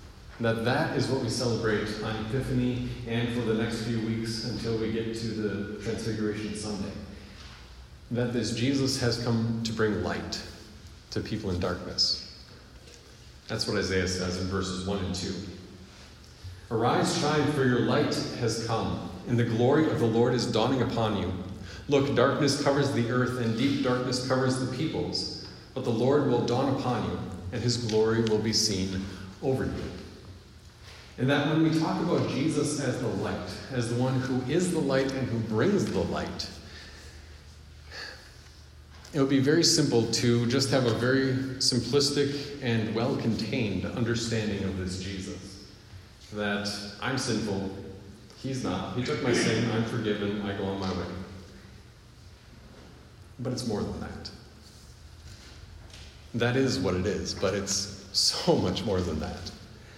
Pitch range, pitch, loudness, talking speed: 95-125 Hz, 110 Hz, -28 LUFS, 160 wpm